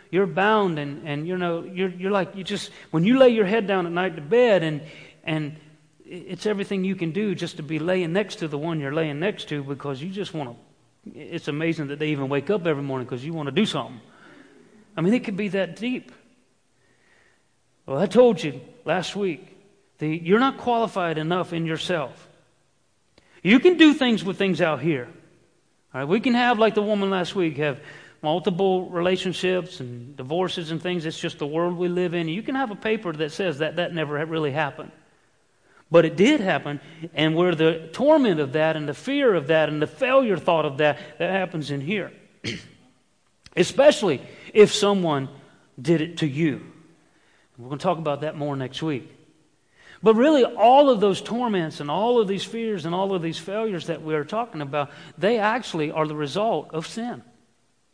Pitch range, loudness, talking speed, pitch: 155-200 Hz, -23 LUFS, 205 wpm, 170 Hz